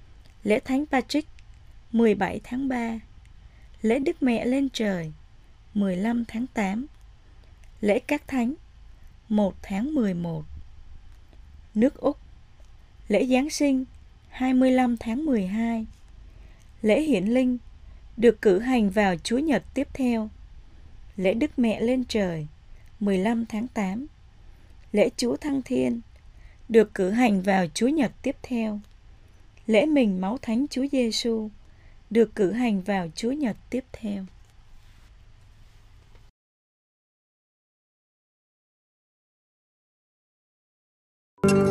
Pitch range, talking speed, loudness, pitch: 185-250 Hz, 105 wpm, -25 LUFS, 220 Hz